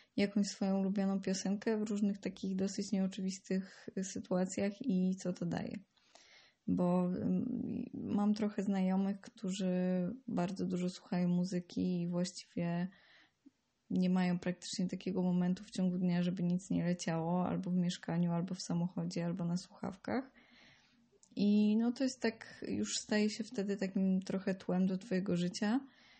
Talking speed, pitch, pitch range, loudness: 140 wpm, 190 Hz, 180-210 Hz, -36 LUFS